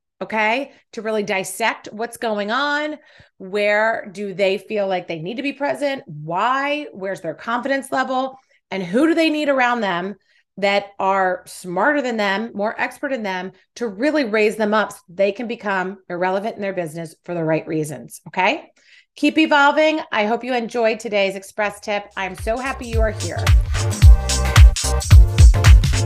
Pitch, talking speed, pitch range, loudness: 205 Hz, 165 wpm, 185-250 Hz, -19 LUFS